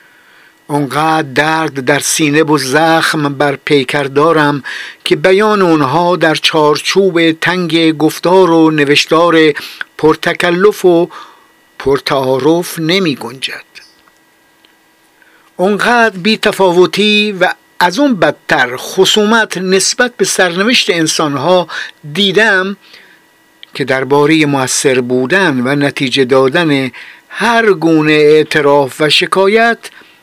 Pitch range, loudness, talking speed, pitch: 145-190 Hz, -10 LUFS, 95 wpm, 165 Hz